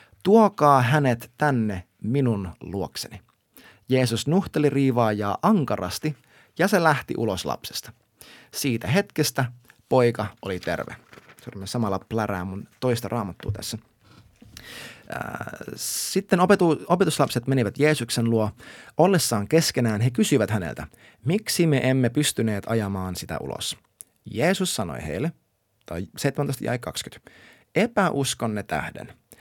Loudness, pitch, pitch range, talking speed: -24 LUFS, 120 Hz, 105-150 Hz, 95 wpm